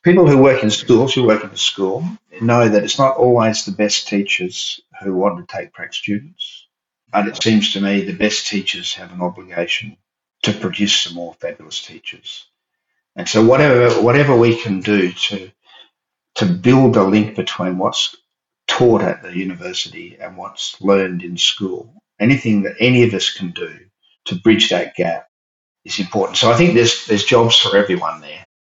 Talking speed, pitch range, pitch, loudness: 180 wpm, 95-120 Hz, 105 Hz, -15 LUFS